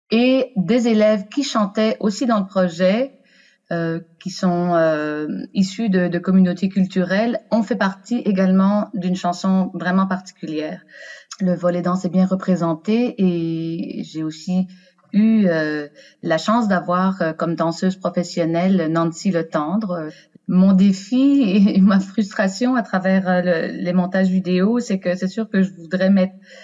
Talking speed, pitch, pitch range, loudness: 150 wpm, 185 Hz, 175-210 Hz, -19 LUFS